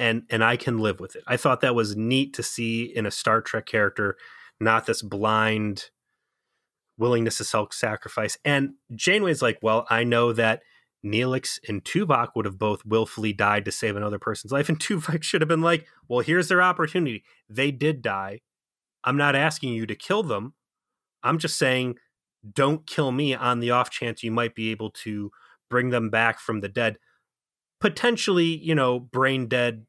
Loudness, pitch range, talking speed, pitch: -24 LUFS, 110-140 Hz, 185 wpm, 120 Hz